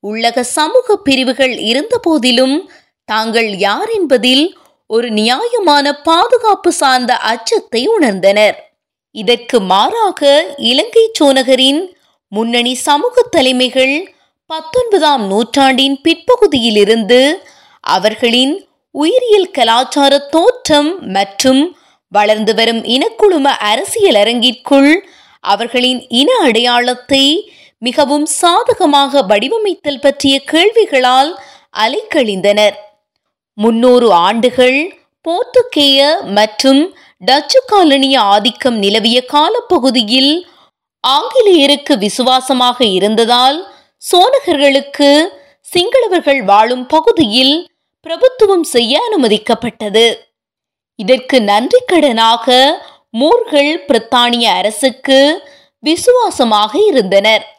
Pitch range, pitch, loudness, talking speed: 240-330 Hz, 275 Hz, -10 LUFS, 65 wpm